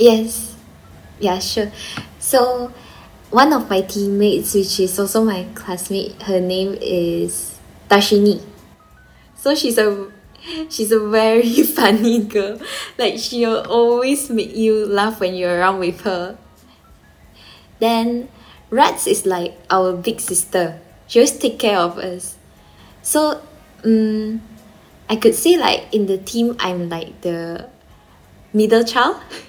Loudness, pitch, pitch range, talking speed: -17 LUFS, 210 Hz, 180-230 Hz, 130 wpm